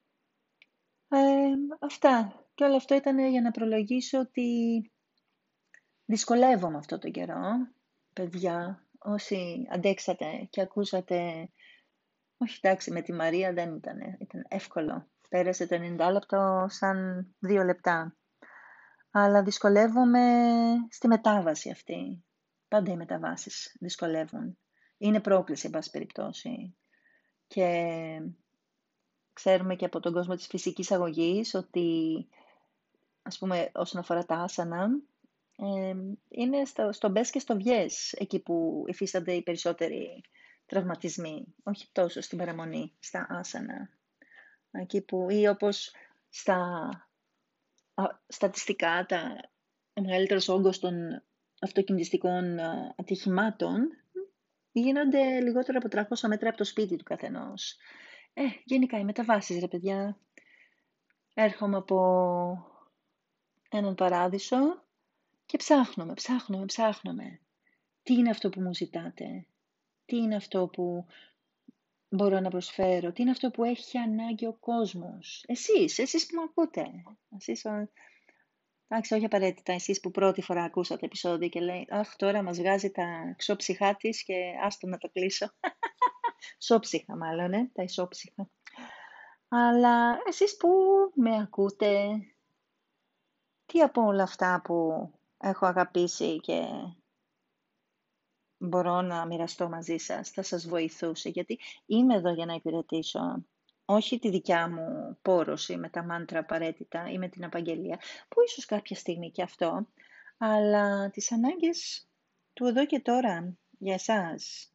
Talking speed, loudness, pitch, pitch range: 120 wpm, -29 LUFS, 200 Hz, 180-240 Hz